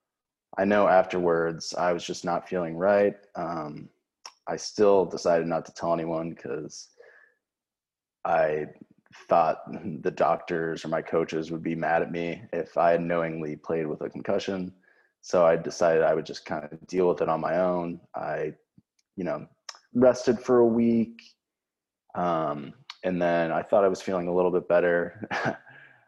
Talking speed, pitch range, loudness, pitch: 165 wpm, 80-95 Hz, -26 LUFS, 85 Hz